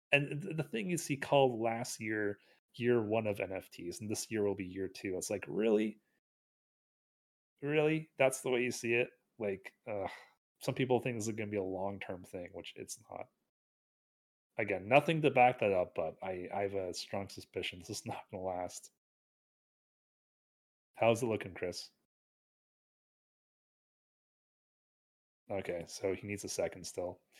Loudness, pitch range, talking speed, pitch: -36 LUFS, 100-135 Hz, 165 wpm, 115 Hz